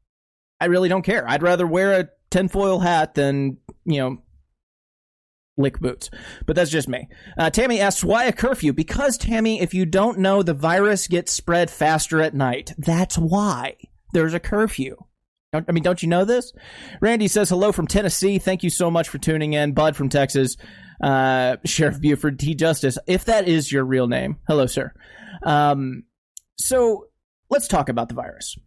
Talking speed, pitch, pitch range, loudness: 175 wpm, 170 Hz, 145-195 Hz, -20 LUFS